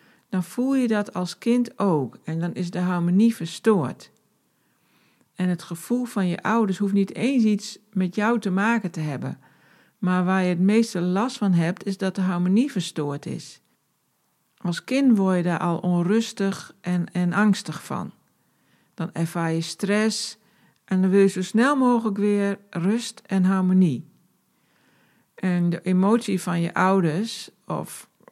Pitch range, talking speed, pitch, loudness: 175-215 Hz, 160 wpm, 190 Hz, -23 LUFS